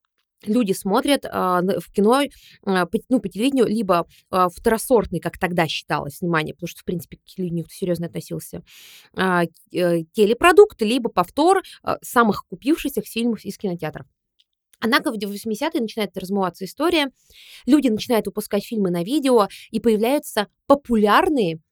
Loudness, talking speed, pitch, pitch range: -21 LUFS, 140 wpm, 210 Hz, 180-240 Hz